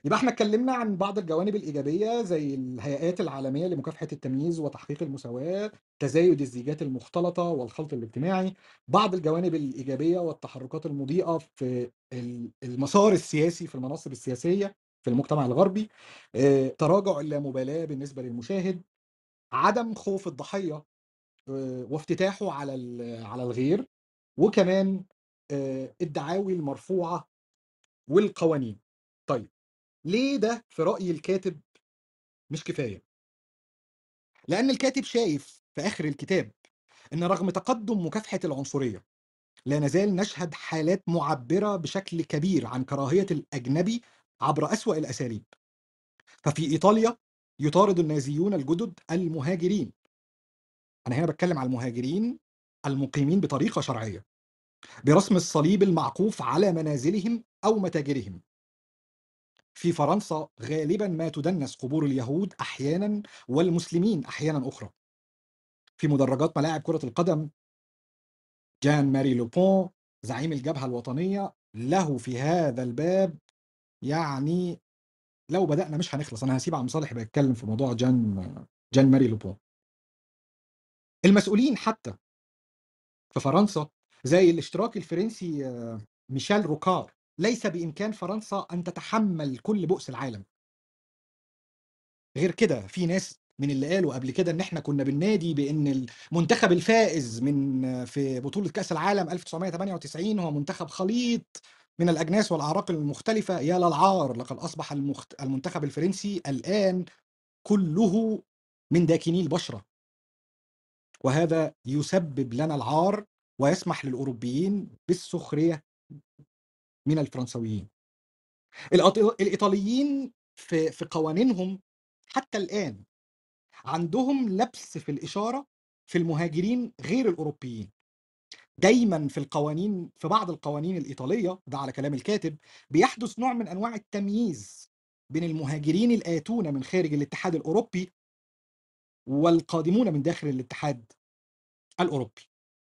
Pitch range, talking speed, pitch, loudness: 135-190 Hz, 105 wpm, 160 Hz, -27 LUFS